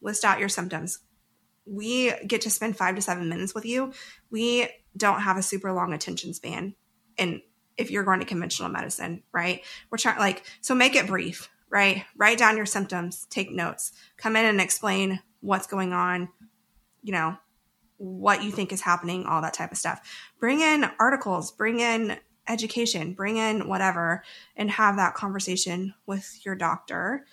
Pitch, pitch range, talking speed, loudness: 200 Hz, 185-220 Hz, 175 wpm, -26 LUFS